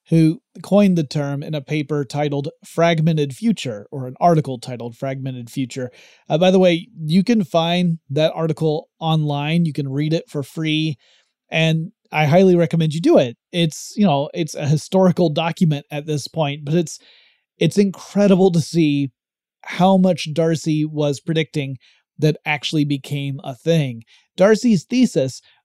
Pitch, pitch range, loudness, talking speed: 160 Hz, 145-175 Hz, -19 LUFS, 155 wpm